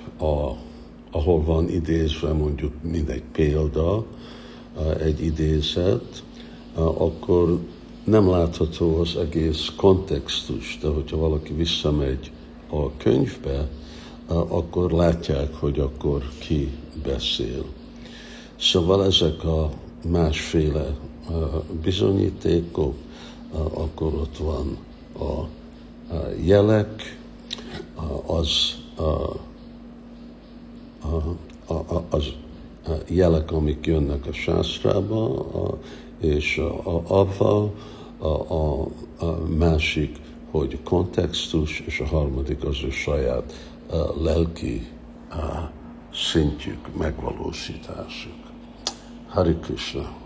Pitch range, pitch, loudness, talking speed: 80-85 Hz, 80 Hz, -24 LUFS, 90 wpm